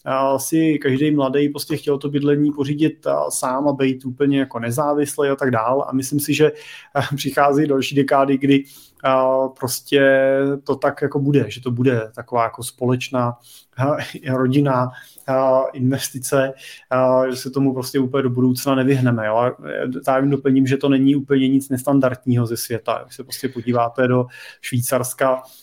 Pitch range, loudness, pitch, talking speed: 130-140 Hz, -19 LUFS, 135 Hz, 165 wpm